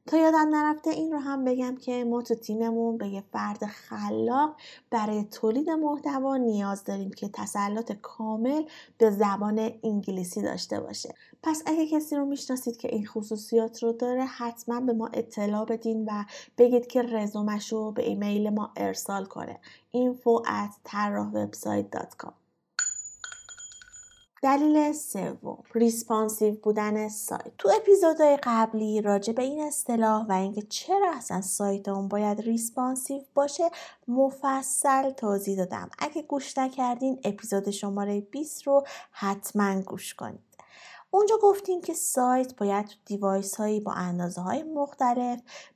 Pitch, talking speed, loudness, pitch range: 230 Hz, 130 wpm, -28 LUFS, 205-275 Hz